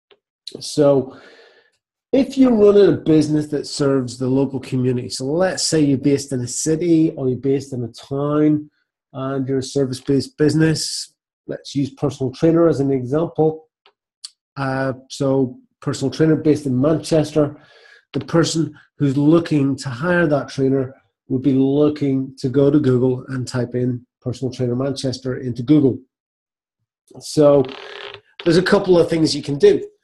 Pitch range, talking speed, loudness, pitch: 130-155 Hz, 155 wpm, -18 LUFS, 140 Hz